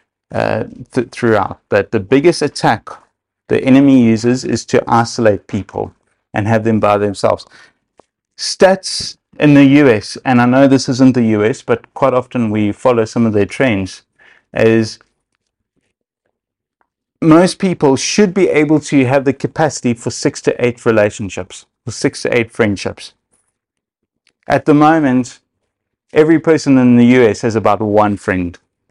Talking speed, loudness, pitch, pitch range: 145 wpm, -13 LUFS, 120 Hz, 110-140 Hz